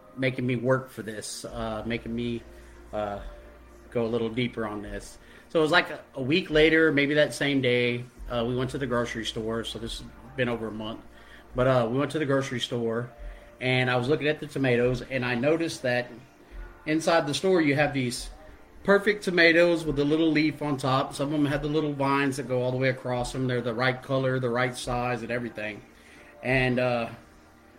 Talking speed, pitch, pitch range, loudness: 215 wpm, 125 Hz, 115-140 Hz, -26 LUFS